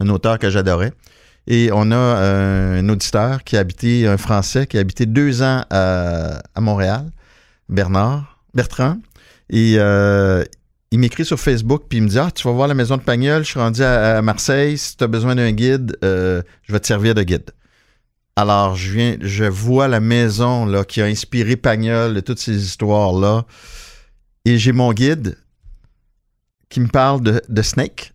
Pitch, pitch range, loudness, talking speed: 115 Hz, 100-125 Hz, -16 LUFS, 190 wpm